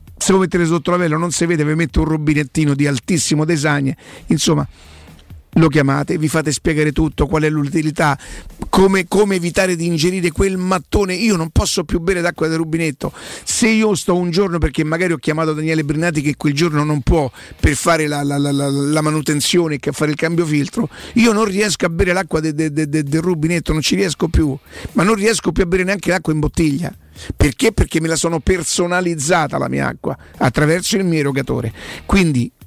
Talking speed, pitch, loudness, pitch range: 200 wpm, 160 Hz, -17 LUFS, 150-180 Hz